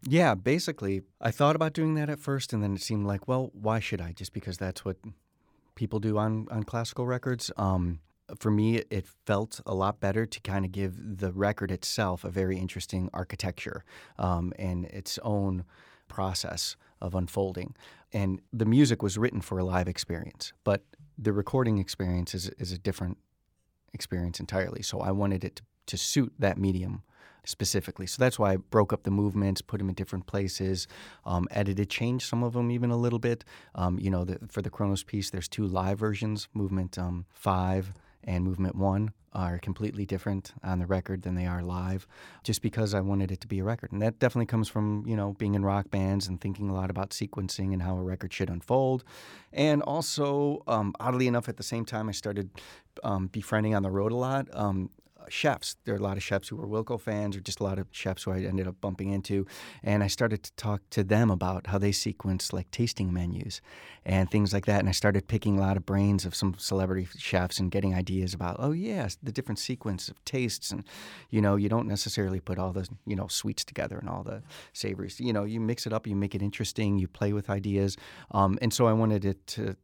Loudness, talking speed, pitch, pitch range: -30 LUFS, 215 wpm, 100 Hz, 95-110 Hz